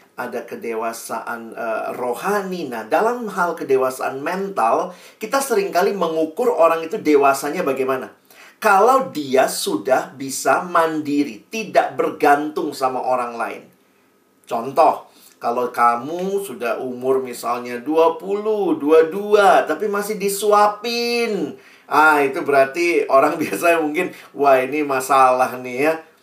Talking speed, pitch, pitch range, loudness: 110 wpm, 160 Hz, 130-200 Hz, -19 LUFS